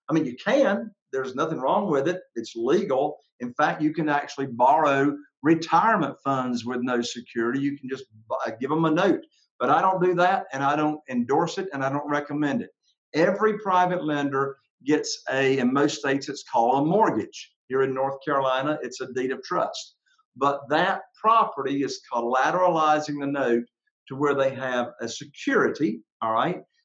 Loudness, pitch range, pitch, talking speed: -24 LUFS, 135-180 Hz, 145 Hz, 180 wpm